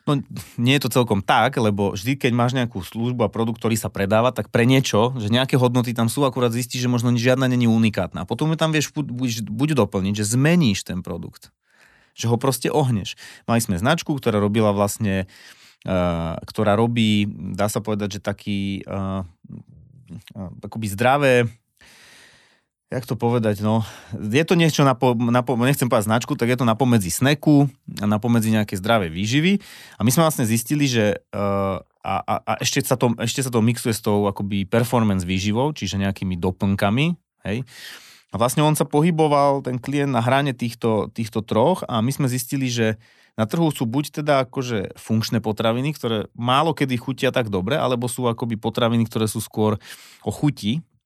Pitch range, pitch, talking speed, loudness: 105-130 Hz, 115 Hz, 180 wpm, -21 LUFS